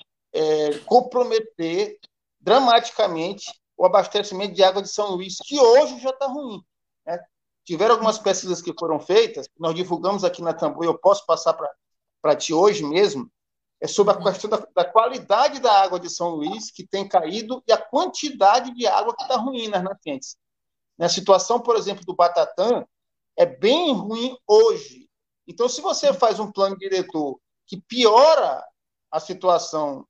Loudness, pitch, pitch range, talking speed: -20 LUFS, 200 Hz, 180-255 Hz, 160 wpm